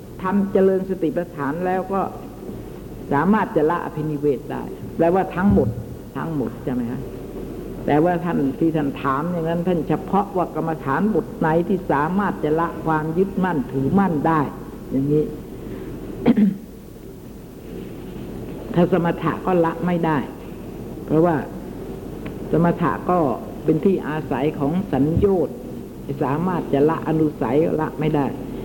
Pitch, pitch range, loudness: 165 Hz, 150-185 Hz, -21 LUFS